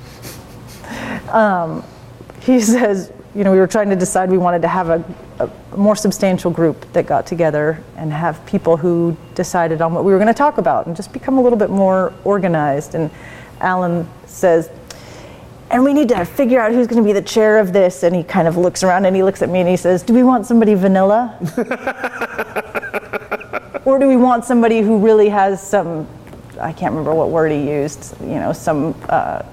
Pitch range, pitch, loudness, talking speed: 170-225 Hz, 190 Hz, -15 LUFS, 200 wpm